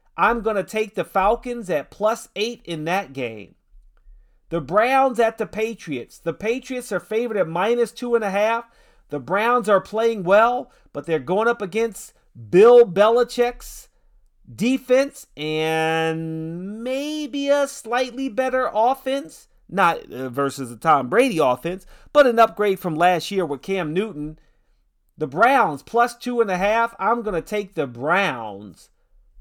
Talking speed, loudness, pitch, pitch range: 150 wpm, -21 LUFS, 215 Hz, 170-240 Hz